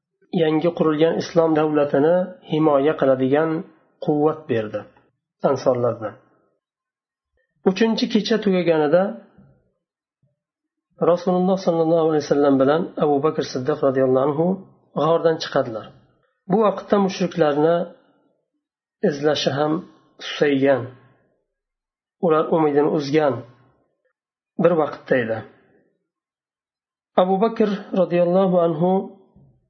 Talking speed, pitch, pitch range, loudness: 80 wpm, 165 Hz, 150-185 Hz, -20 LUFS